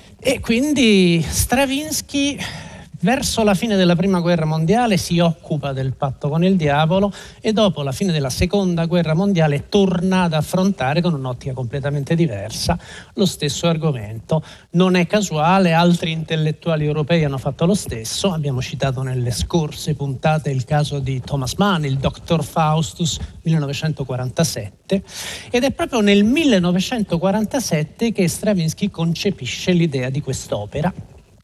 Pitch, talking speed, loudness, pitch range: 165 Hz, 135 wpm, -19 LUFS, 145-190 Hz